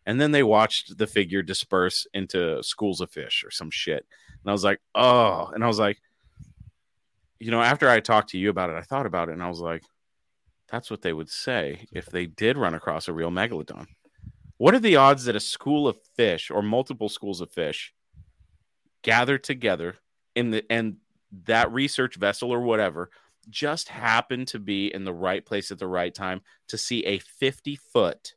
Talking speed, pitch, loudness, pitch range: 200 wpm, 110 Hz, -24 LUFS, 95-130 Hz